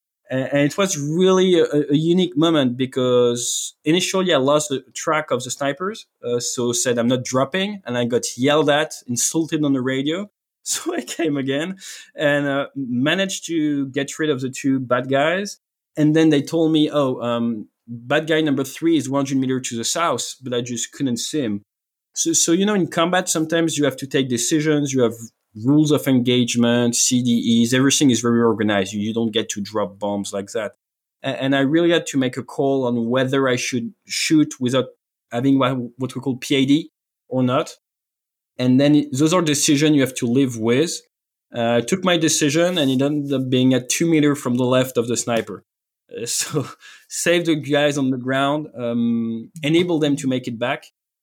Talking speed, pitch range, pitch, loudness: 190 wpm, 125-155 Hz, 135 Hz, -19 LUFS